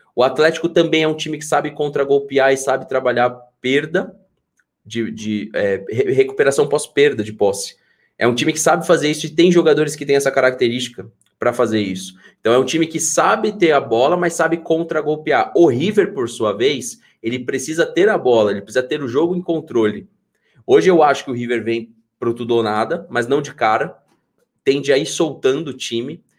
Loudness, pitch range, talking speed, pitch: -17 LUFS, 120-170 Hz, 200 wpm, 145 Hz